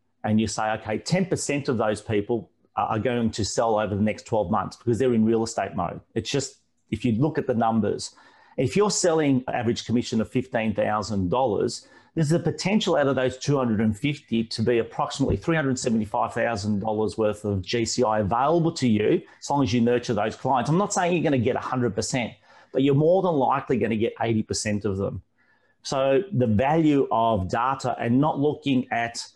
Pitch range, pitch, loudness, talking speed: 110-140 Hz, 120 Hz, -24 LUFS, 185 wpm